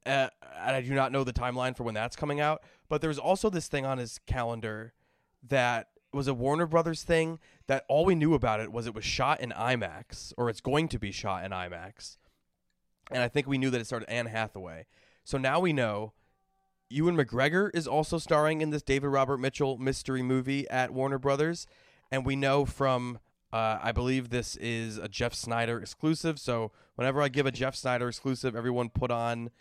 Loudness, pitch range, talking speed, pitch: -30 LUFS, 115-145 Hz, 205 wpm, 130 Hz